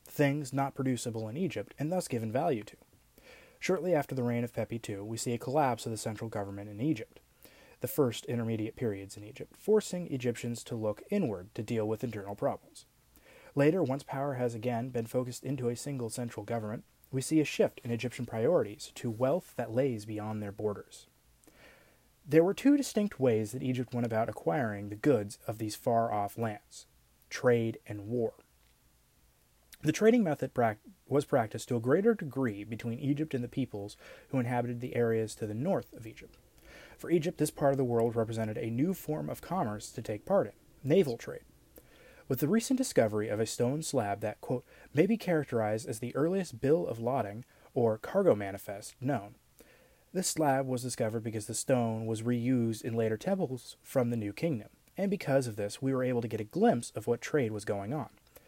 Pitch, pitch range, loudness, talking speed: 120 Hz, 110-140 Hz, -32 LUFS, 195 wpm